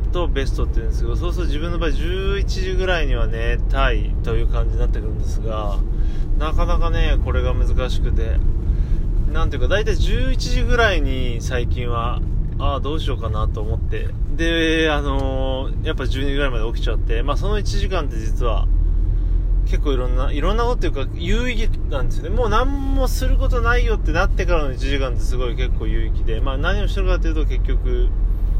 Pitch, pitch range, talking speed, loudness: 95 Hz, 90-115 Hz, 395 characters per minute, -22 LUFS